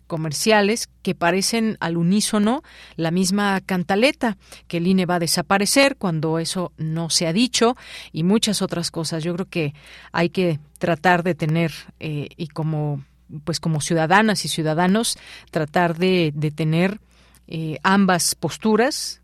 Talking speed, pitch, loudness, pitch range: 145 wpm, 175 Hz, -20 LUFS, 165-195 Hz